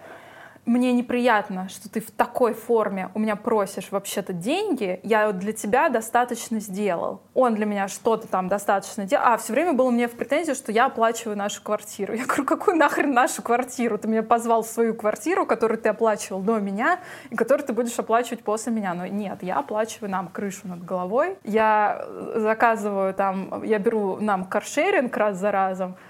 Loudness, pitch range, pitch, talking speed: -23 LUFS, 205-240 Hz, 220 Hz, 180 wpm